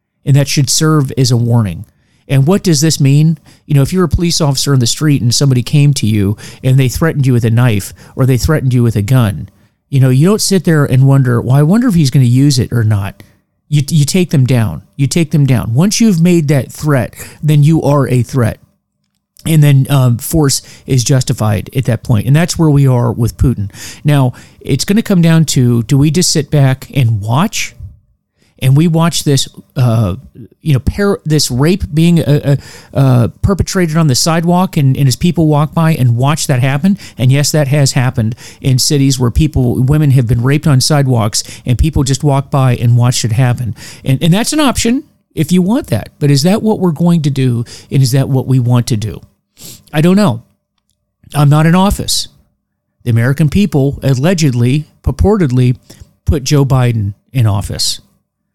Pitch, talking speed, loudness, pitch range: 135 Hz, 205 wpm, -11 LUFS, 120-155 Hz